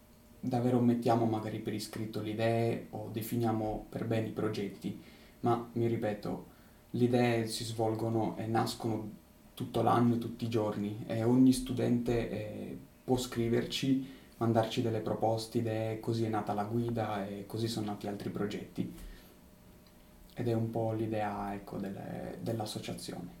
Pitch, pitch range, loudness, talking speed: 110 Hz, 105-115 Hz, -34 LUFS, 145 wpm